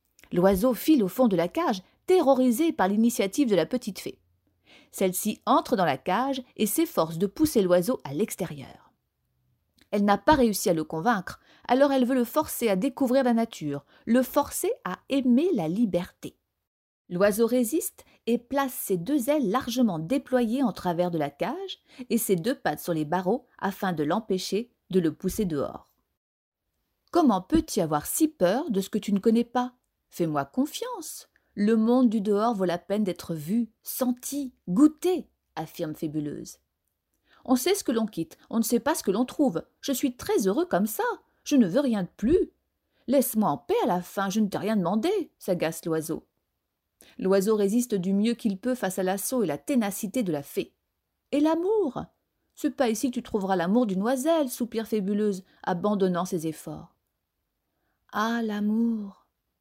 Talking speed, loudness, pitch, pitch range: 175 wpm, -26 LUFS, 225 Hz, 185-265 Hz